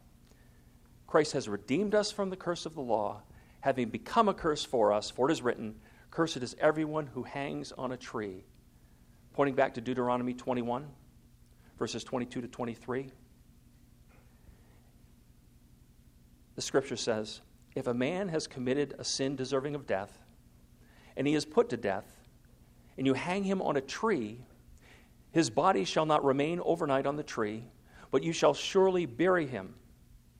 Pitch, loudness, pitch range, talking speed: 130 Hz, -32 LUFS, 115-155 Hz, 155 wpm